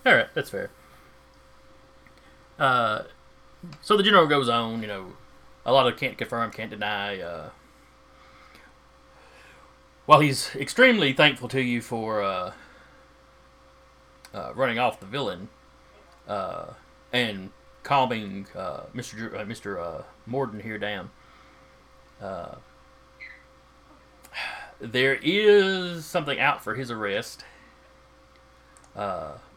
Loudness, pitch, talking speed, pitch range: -24 LUFS, 125 Hz, 110 wpm, 105-150 Hz